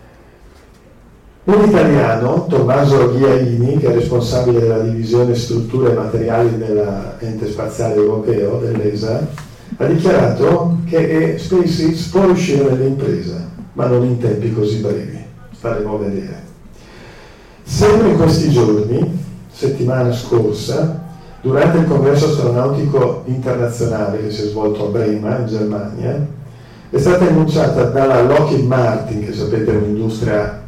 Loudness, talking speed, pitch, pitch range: -15 LUFS, 120 wpm, 120 Hz, 110-145 Hz